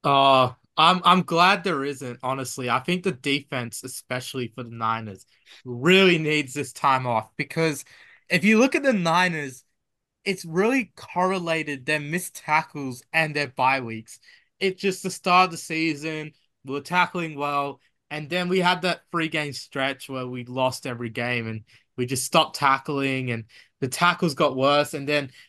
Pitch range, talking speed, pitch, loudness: 130-175 Hz, 175 wpm, 145 Hz, -23 LUFS